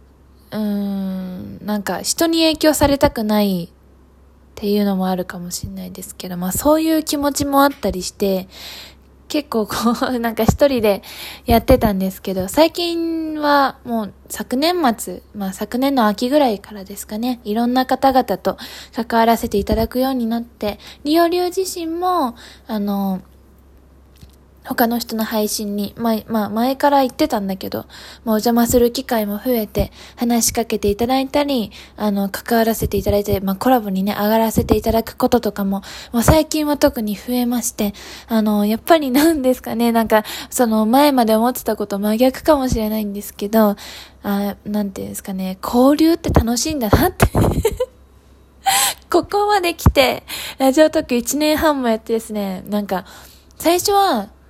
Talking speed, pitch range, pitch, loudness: 335 characters per minute, 205-270 Hz, 225 Hz, -18 LUFS